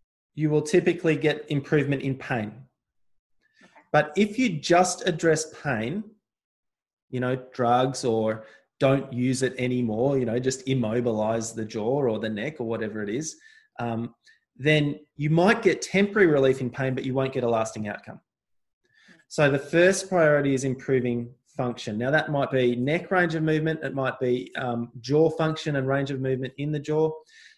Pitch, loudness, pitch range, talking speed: 135 Hz, -25 LUFS, 125-155 Hz, 170 wpm